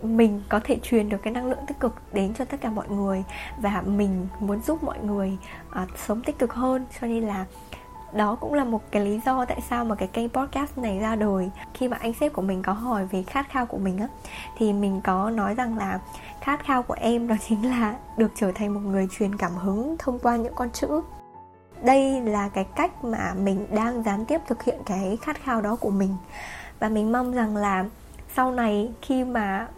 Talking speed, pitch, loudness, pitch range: 225 wpm, 220 Hz, -26 LUFS, 200-250 Hz